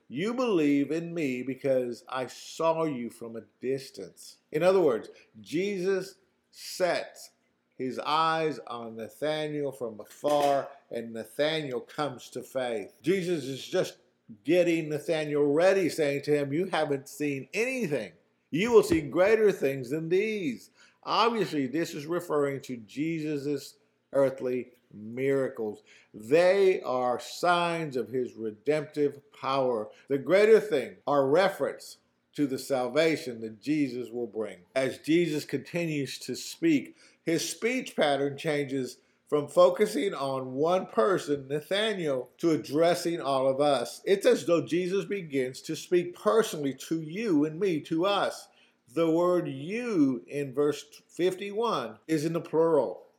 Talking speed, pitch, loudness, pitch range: 135 wpm, 150 Hz, -28 LUFS, 130-175 Hz